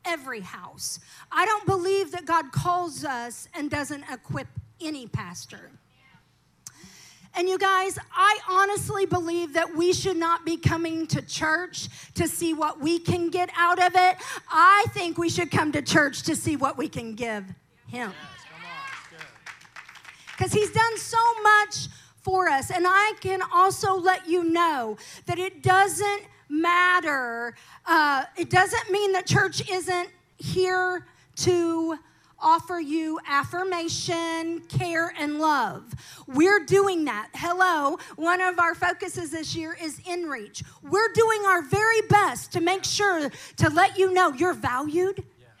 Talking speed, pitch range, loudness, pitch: 145 wpm, 320-375 Hz, -24 LUFS, 350 Hz